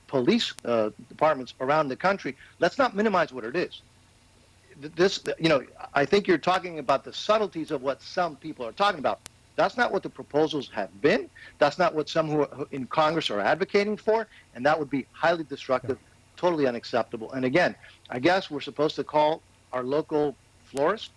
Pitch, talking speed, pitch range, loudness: 150 Hz, 185 wpm, 130-175 Hz, -26 LUFS